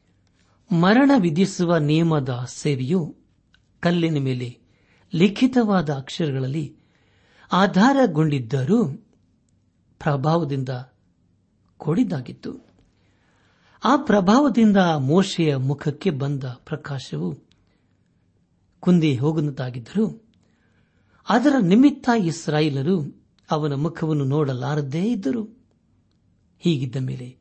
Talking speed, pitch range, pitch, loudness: 60 wpm, 130-190 Hz, 155 Hz, -21 LUFS